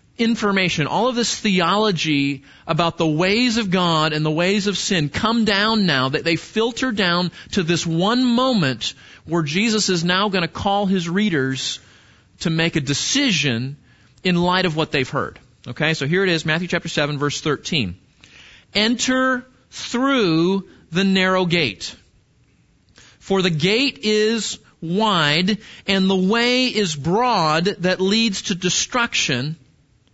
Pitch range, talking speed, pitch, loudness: 155-215 Hz, 145 wpm, 185 Hz, -19 LUFS